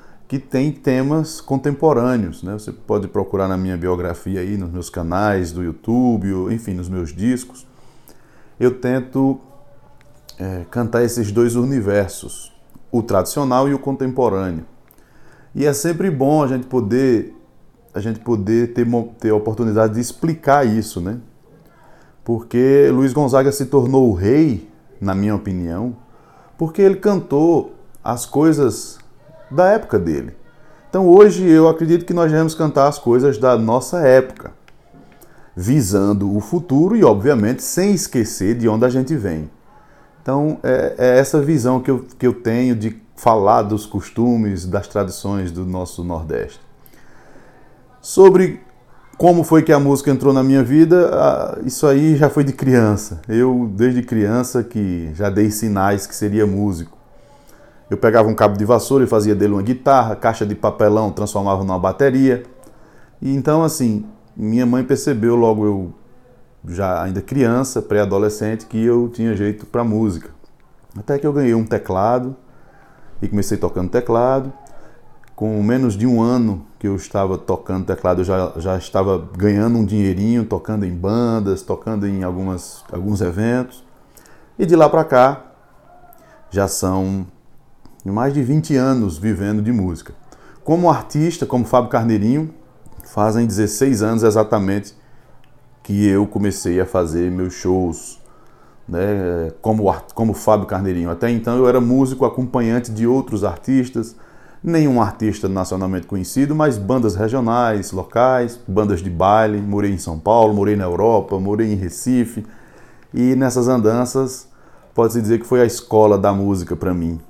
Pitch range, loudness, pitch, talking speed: 100-130 Hz, -17 LUFS, 115 Hz, 145 wpm